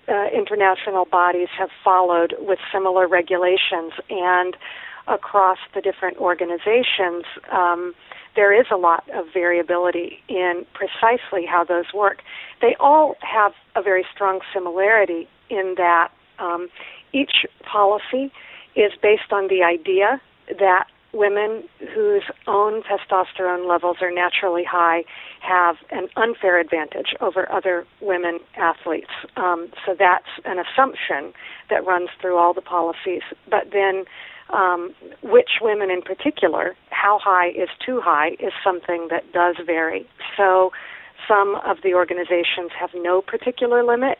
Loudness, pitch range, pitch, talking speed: -20 LUFS, 175-205 Hz, 185 Hz, 130 wpm